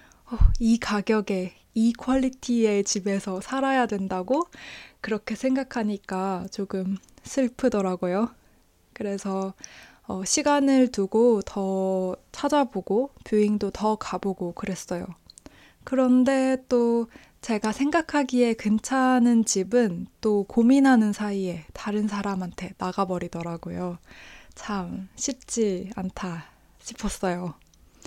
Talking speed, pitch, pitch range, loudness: 225 characters per minute, 210 Hz, 190-250 Hz, -25 LUFS